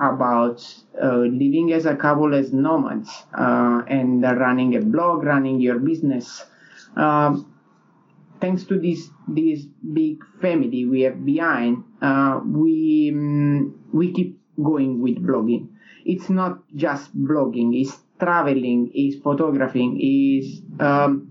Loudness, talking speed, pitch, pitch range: -20 LUFS, 125 wpm, 145 Hz, 130-165 Hz